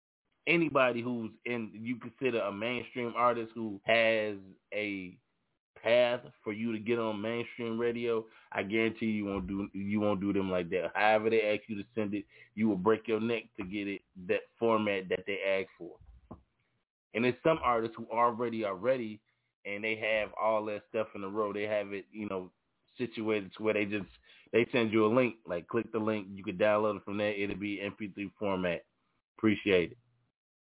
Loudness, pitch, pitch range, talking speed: -32 LUFS, 110 Hz, 100-115 Hz, 195 wpm